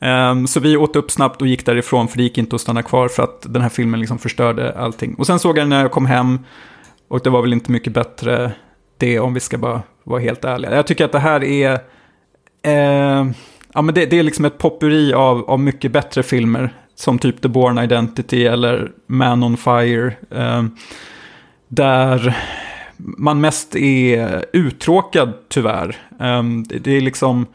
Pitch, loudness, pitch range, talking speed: 125 Hz, -16 LUFS, 120-140 Hz, 190 wpm